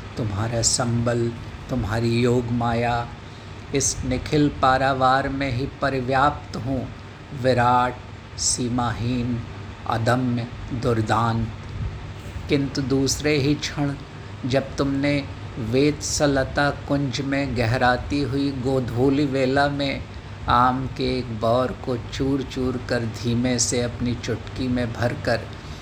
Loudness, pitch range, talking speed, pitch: -23 LUFS, 115-135 Hz, 105 wpm, 125 Hz